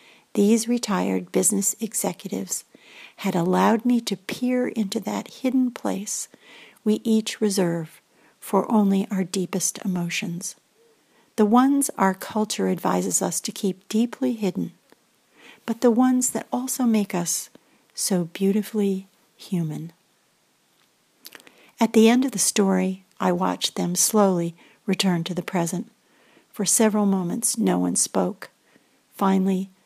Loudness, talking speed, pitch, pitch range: -23 LUFS, 125 wpm, 200 Hz, 185-225 Hz